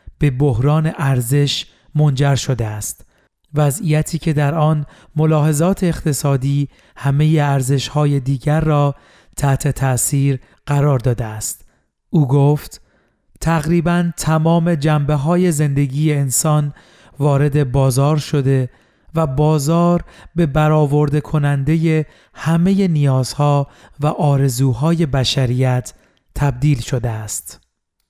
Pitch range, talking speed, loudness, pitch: 135-155 Hz, 100 wpm, -17 LUFS, 145 Hz